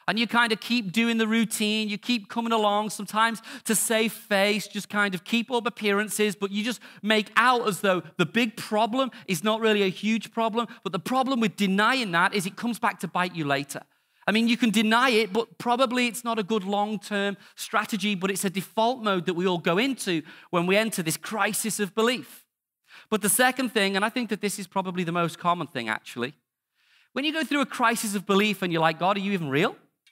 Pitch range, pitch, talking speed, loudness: 195-230 Hz, 215 Hz, 230 wpm, -25 LUFS